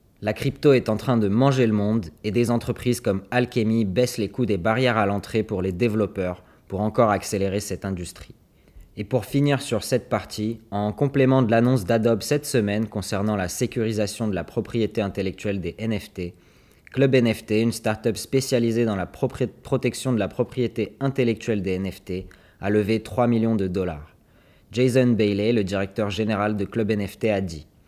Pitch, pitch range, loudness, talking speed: 110 Hz, 100-120 Hz, -23 LUFS, 175 wpm